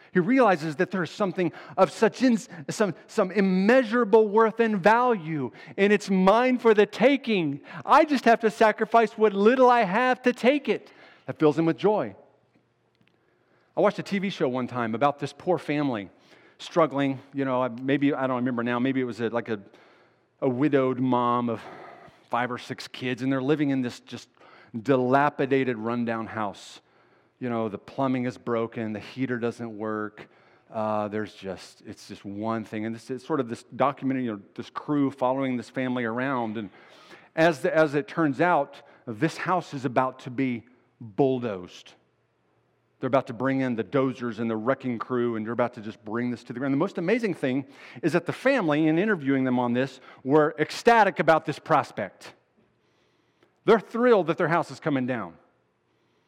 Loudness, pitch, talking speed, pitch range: -25 LUFS, 140 Hz, 185 wpm, 120-185 Hz